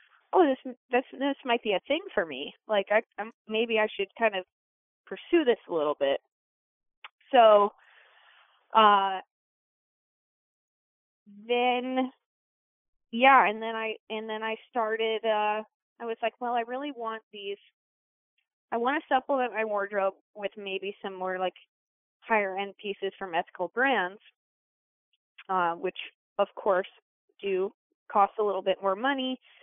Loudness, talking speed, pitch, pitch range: -28 LUFS, 145 wpm, 220 Hz, 200-255 Hz